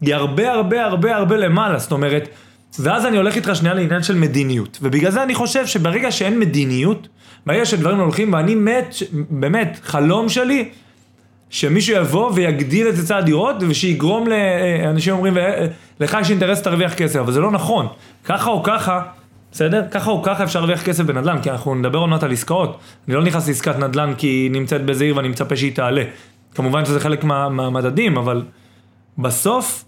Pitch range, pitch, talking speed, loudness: 140-200 Hz, 165 Hz, 160 wpm, -17 LUFS